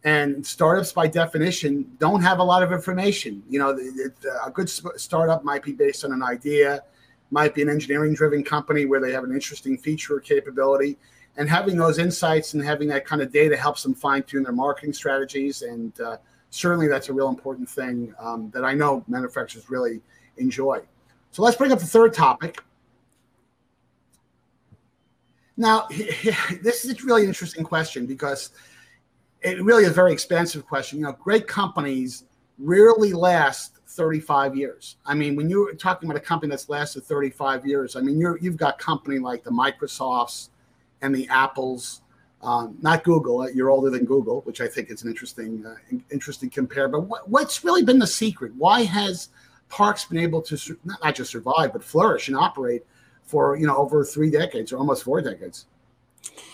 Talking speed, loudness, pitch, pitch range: 180 wpm, -22 LUFS, 145 Hz, 135-180 Hz